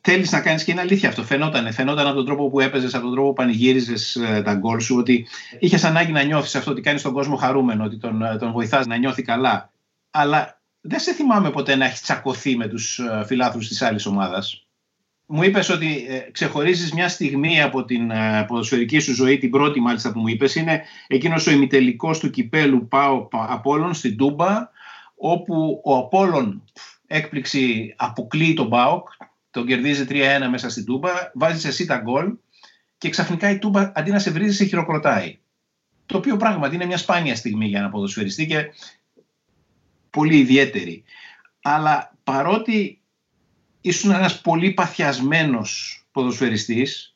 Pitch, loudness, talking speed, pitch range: 140 Hz, -20 LUFS, 165 wpm, 125-170 Hz